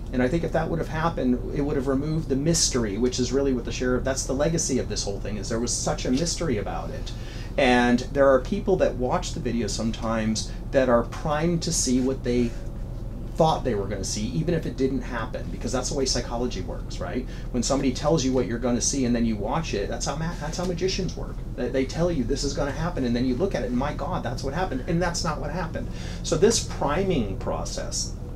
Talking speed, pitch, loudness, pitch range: 245 wpm, 130 Hz, -25 LUFS, 120-145 Hz